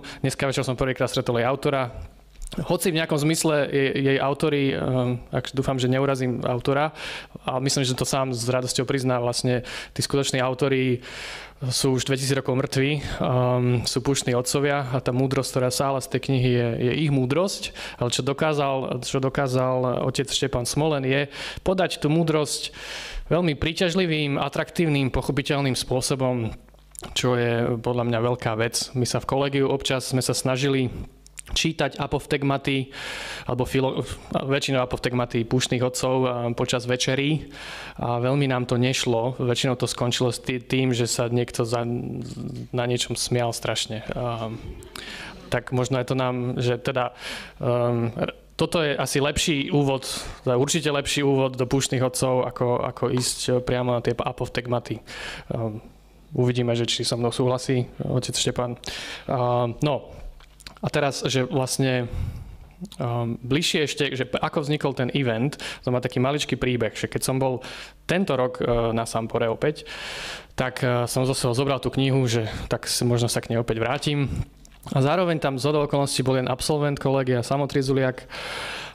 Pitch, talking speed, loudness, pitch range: 130 Hz, 155 wpm, -24 LUFS, 125-140 Hz